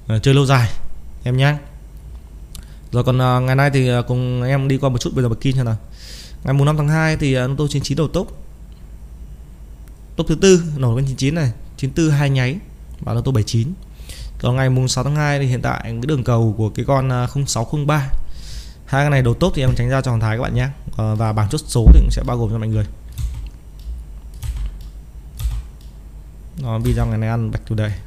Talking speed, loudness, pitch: 205 wpm, -18 LUFS, 120 Hz